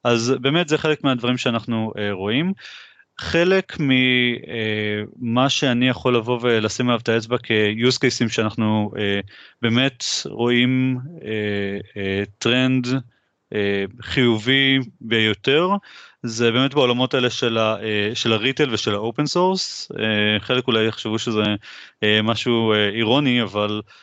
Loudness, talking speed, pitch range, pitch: -20 LUFS, 125 wpm, 110-130 Hz, 120 Hz